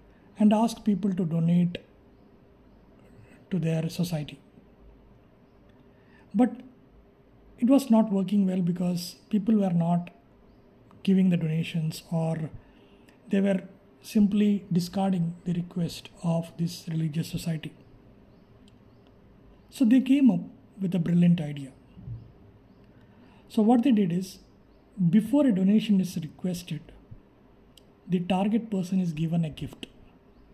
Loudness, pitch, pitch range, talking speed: -26 LUFS, 180 Hz, 165-205 Hz, 110 wpm